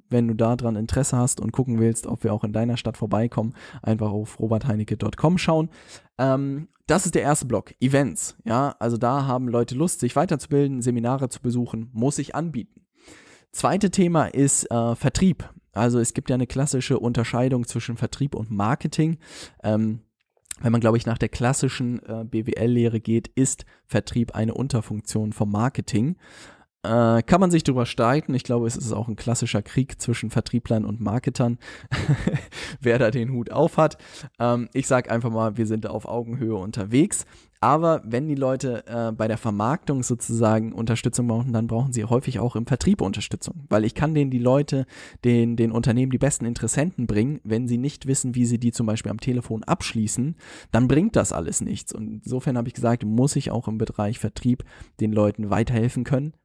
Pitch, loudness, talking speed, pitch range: 120 Hz, -23 LUFS, 180 wpm, 110-135 Hz